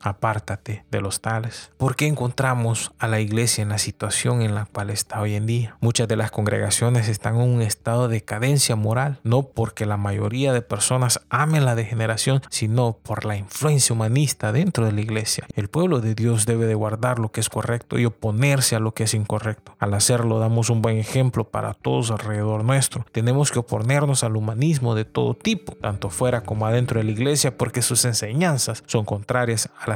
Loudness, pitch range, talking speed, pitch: -22 LUFS, 110-125 Hz, 200 wpm, 115 Hz